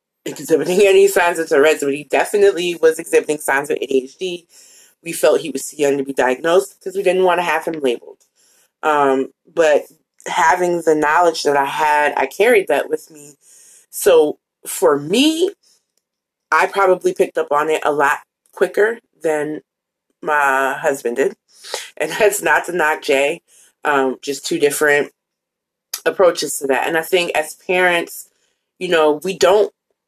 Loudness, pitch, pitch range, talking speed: -16 LUFS, 170 Hz, 145-210 Hz, 160 wpm